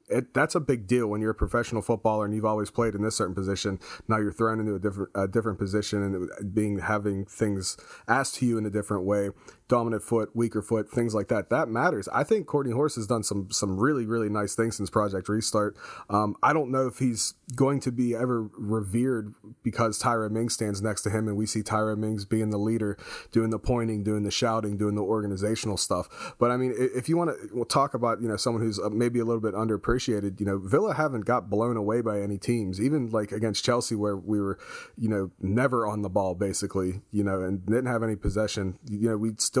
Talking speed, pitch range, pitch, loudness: 235 wpm, 105-120 Hz, 110 Hz, -27 LUFS